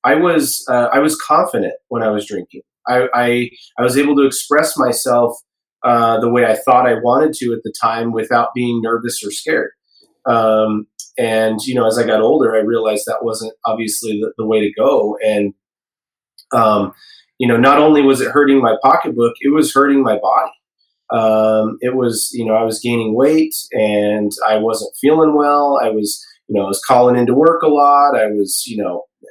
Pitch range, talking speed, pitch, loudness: 110-130 Hz, 200 wpm, 115 Hz, -14 LUFS